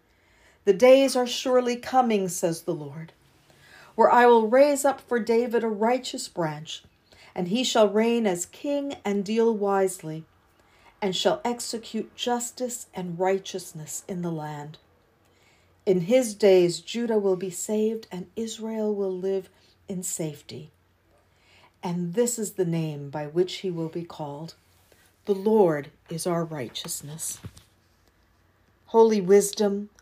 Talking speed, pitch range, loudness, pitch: 135 wpm, 150-225 Hz, -25 LUFS, 185 Hz